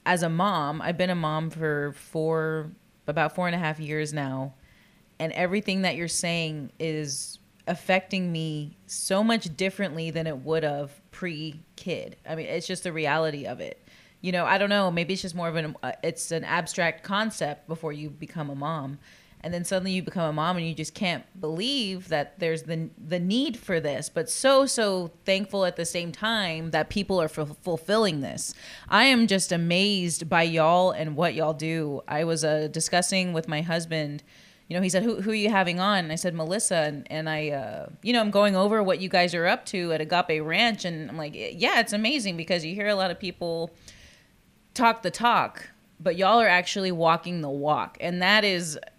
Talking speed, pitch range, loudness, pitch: 205 wpm, 155-190 Hz, -26 LUFS, 170 Hz